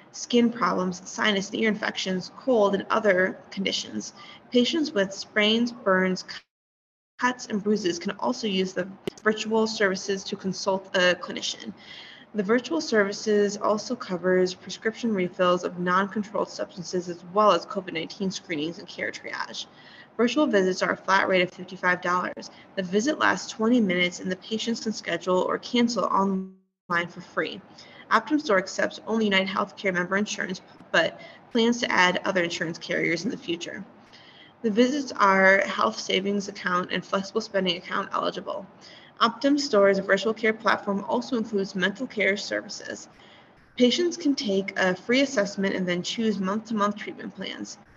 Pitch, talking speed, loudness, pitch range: 195 Hz, 150 wpm, -25 LUFS, 185-220 Hz